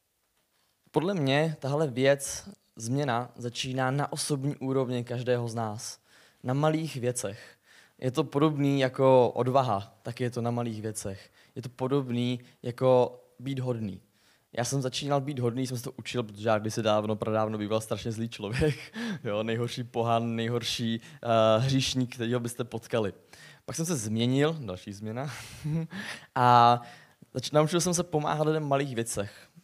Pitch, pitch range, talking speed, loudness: 125 Hz, 115-140 Hz, 150 wpm, -29 LUFS